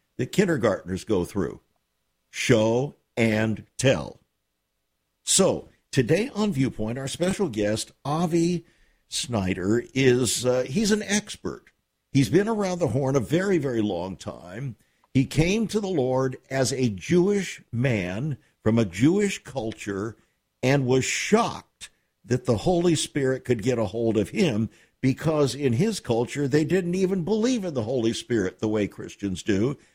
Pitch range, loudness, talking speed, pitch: 115-170 Hz, -25 LUFS, 145 wpm, 130 Hz